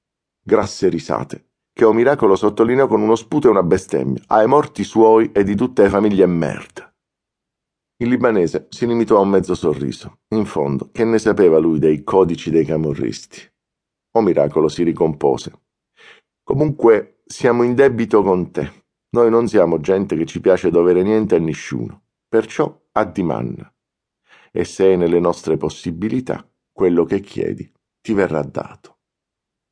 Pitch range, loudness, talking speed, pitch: 85-115 Hz, -17 LUFS, 155 wpm, 105 Hz